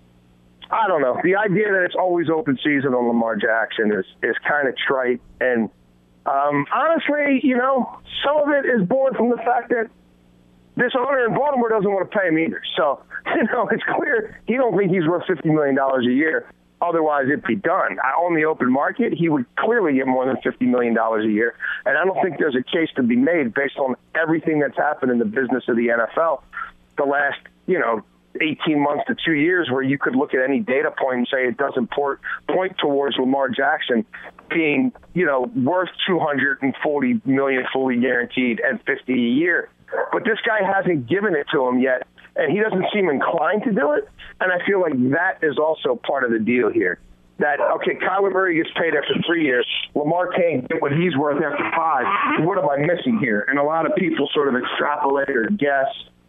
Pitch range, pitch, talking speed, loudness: 125-190 Hz, 140 Hz, 210 wpm, -20 LUFS